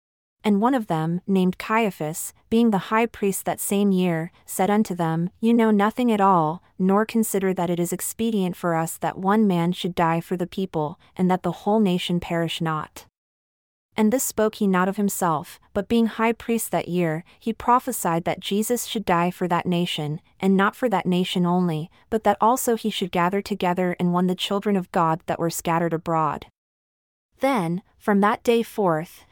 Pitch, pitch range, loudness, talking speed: 185 Hz, 175-215 Hz, -23 LUFS, 190 wpm